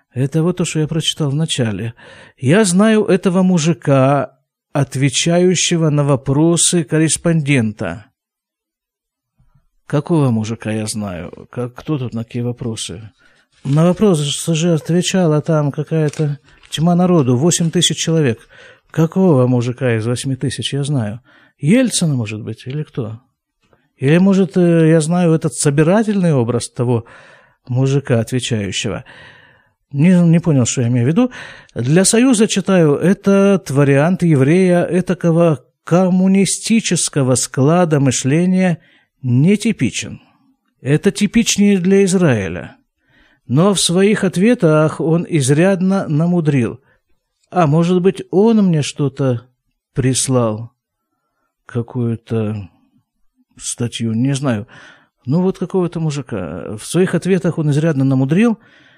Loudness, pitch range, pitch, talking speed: -15 LUFS, 125-180 Hz, 155 Hz, 110 wpm